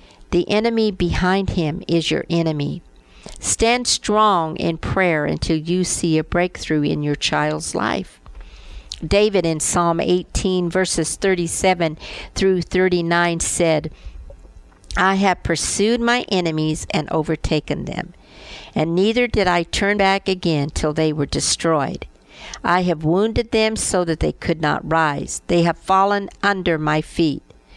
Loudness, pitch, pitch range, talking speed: -19 LUFS, 175 Hz, 155-190 Hz, 140 wpm